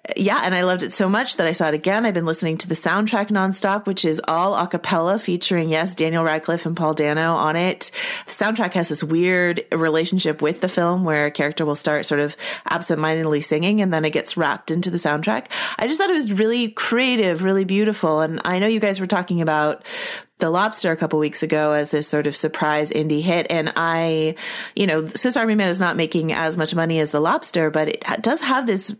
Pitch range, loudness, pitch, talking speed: 155-195 Hz, -20 LUFS, 170 Hz, 230 wpm